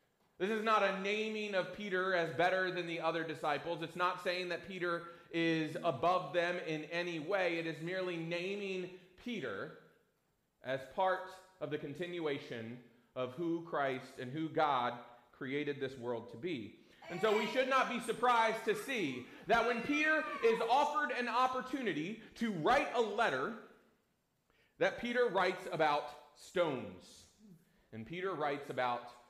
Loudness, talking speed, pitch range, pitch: -36 LUFS, 150 wpm, 155-210 Hz, 175 Hz